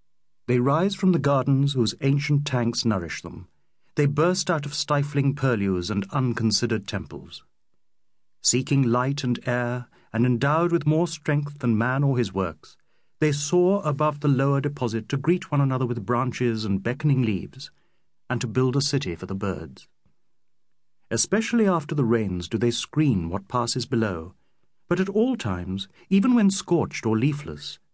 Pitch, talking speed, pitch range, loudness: 130 Hz, 160 wpm, 110-150 Hz, -24 LUFS